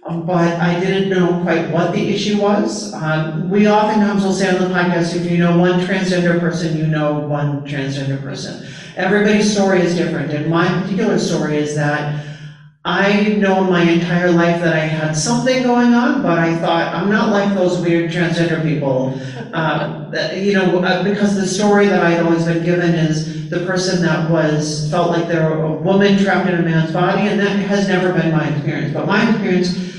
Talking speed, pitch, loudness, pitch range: 195 wpm, 175 Hz, -16 LUFS, 155-190 Hz